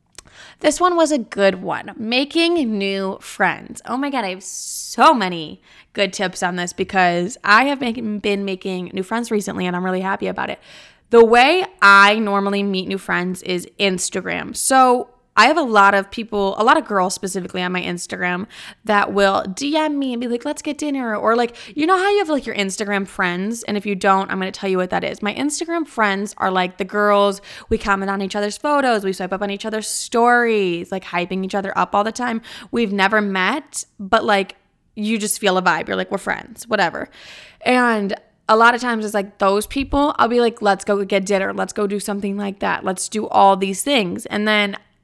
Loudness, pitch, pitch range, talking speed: -18 LUFS, 205 Hz, 195-235 Hz, 215 wpm